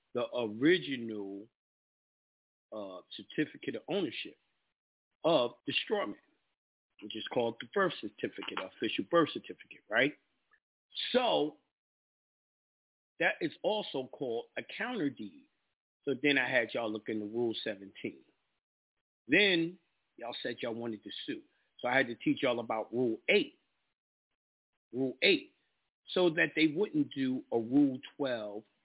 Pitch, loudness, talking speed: 125 Hz, -33 LUFS, 130 wpm